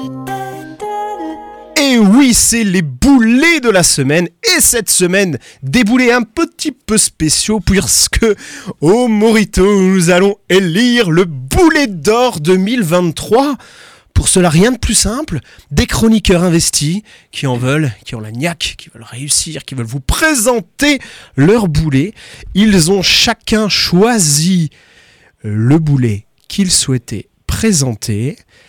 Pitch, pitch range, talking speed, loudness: 190 Hz, 145-235 Hz, 130 wpm, -11 LUFS